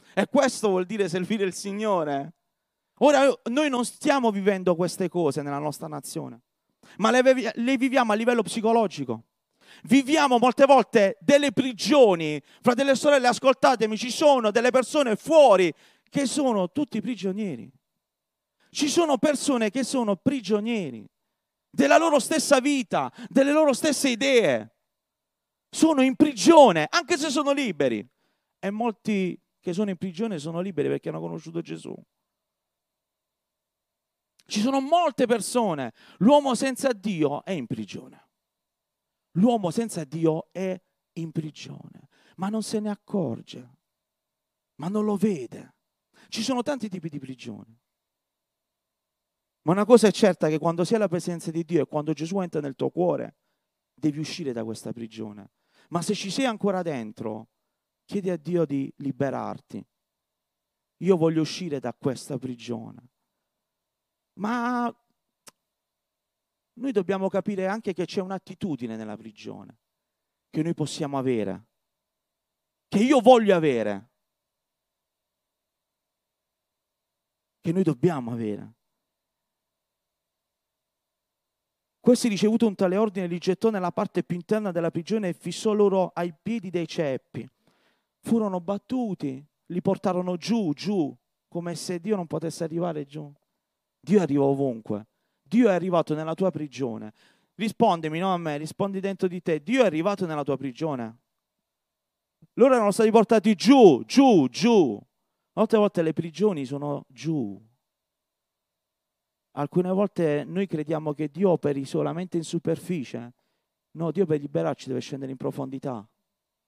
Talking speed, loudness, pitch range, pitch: 130 wpm, -24 LUFS, 155-235 Hz, 190 Hz